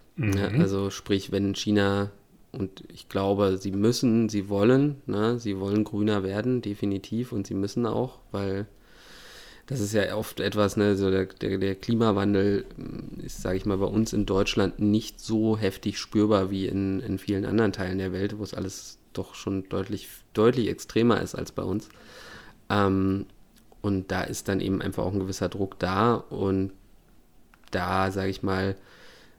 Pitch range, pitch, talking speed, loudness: 95-105 Hz, 100 Hz, 170 wpm, -27 LUFS